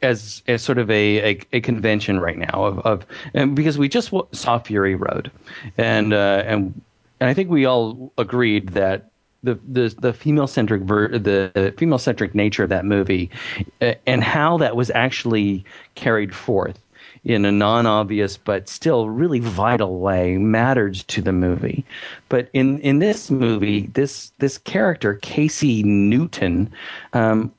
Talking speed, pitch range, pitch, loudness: 155 wpm, 100-130 Hz, 110 Hz, -19 LUFS